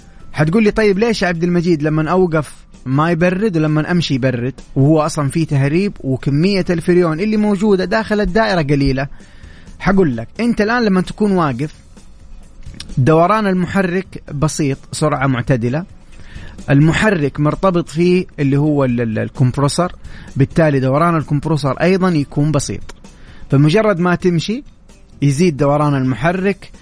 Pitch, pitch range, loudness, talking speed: 155 Hz, 140-185 Hz, -15 LUFS, 125 wpm